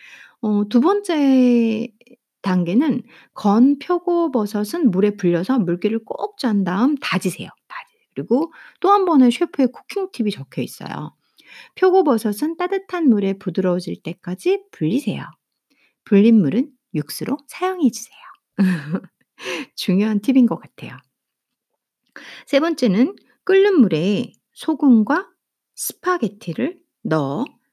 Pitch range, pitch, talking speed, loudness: 205-310 Hz, 245 Hz, 240 characters per minute, -19 LUFS